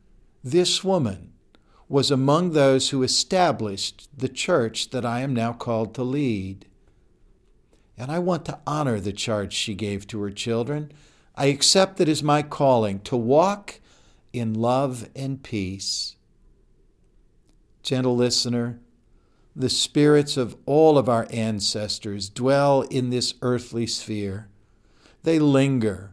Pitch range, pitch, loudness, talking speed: 110-140 Hz, 125 Hz, -23 LUFS, 130 wpm